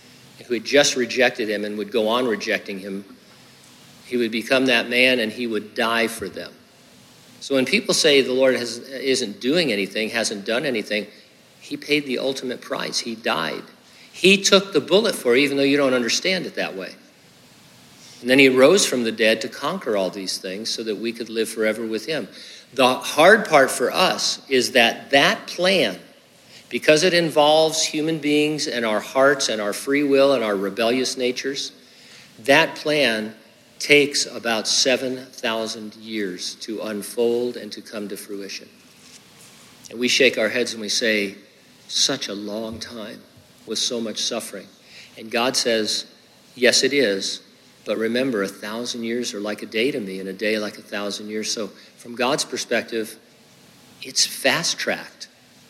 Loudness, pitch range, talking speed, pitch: -20 LUFS, 105-135 Hz, 170 wpm, 120 Hz